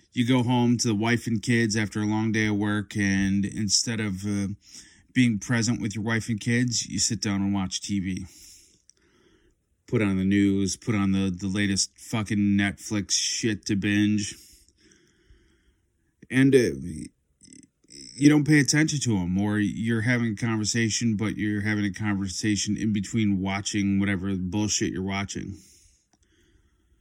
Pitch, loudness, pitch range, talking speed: 105 Hz, -25 LUFS, 100-115 Hz, 155 wpm